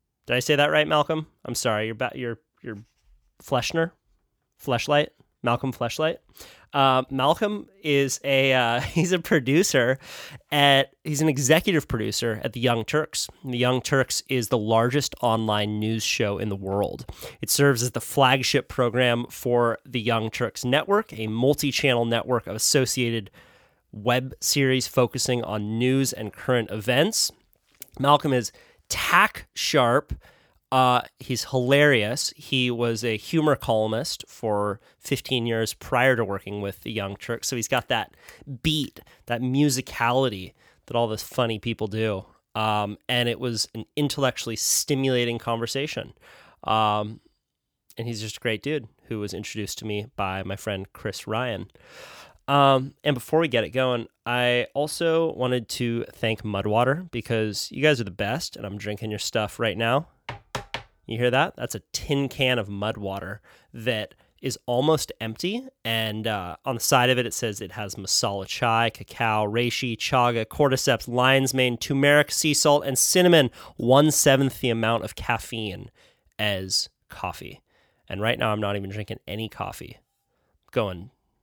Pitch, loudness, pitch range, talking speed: 120 Hz, -24 LUFS, 110-135 Hz, 155 wpm